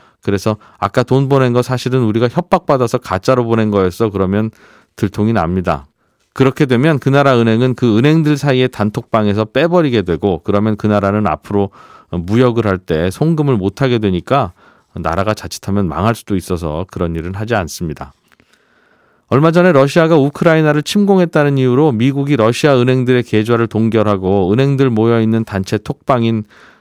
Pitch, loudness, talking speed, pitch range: 115 Hz, -14 LUFS, 370 characters per minute, 100-135 Hz